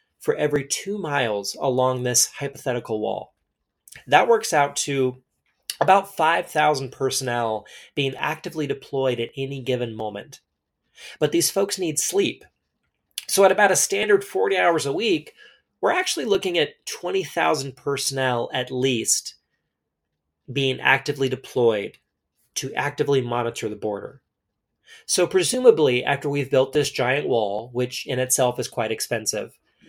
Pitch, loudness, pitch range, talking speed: 140 Hz, -22 LUFS, 125-180 Hz, 135 wpm